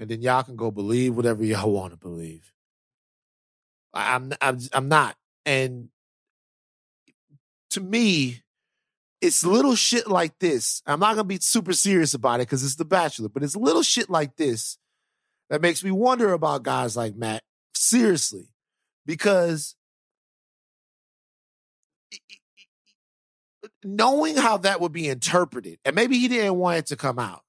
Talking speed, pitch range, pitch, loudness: 145 wpm, 120-200 Hz, 155 Hz, -22 LUFS